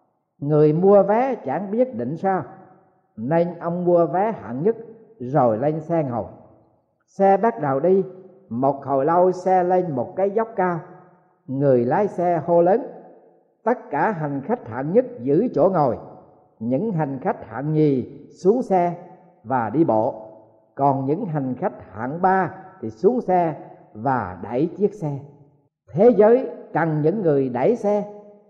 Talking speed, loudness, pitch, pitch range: 155 wpm, -21 LUFS, 170 Hz, 140-195 Hz